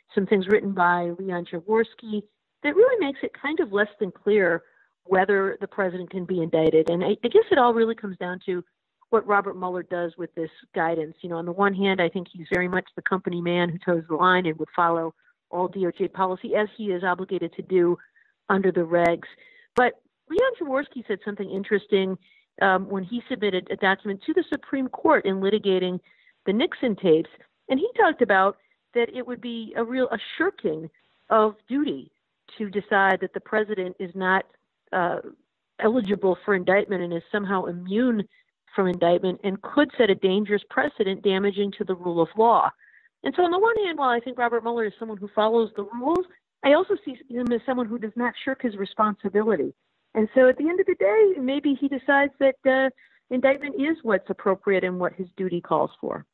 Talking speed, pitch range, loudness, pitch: 200 wpm, 185-250 Hz, -24 LUFS, 205 Hz